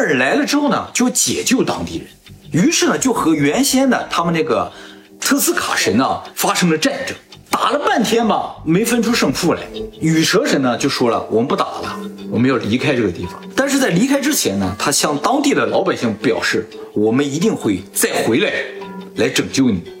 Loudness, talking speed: -16 LUFS, 290 characters per minute